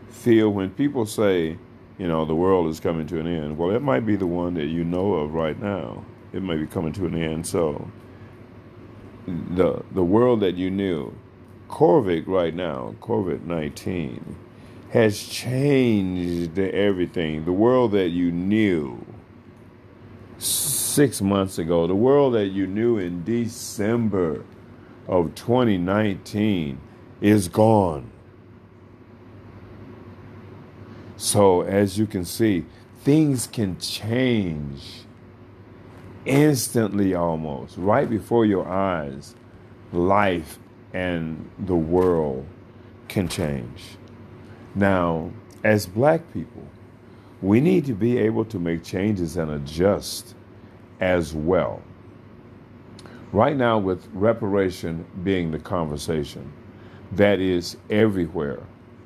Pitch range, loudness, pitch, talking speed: 90-115 Hz, -22 LUFS, 100 Hz, 115 wpm